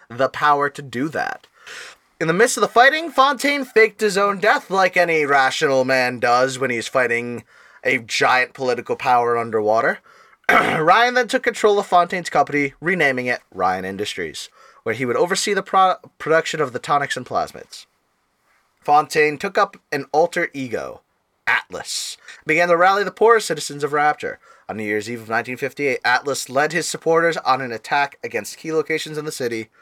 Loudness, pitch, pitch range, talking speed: -19 LUFS, 150 Hz, 130-195 Hz, 175 wpm